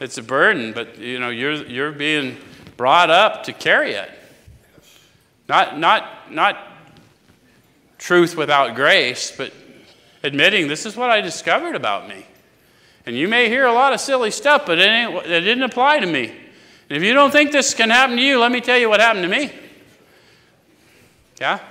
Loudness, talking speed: -16 LUFS, 180 wpm